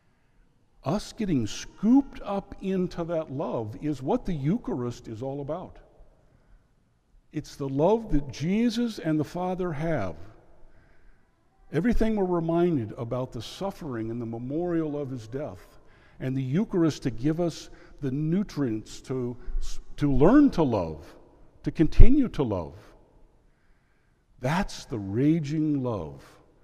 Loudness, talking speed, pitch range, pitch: -28 LUFS, 125 wpm, 125-175 Hz, 150 Hz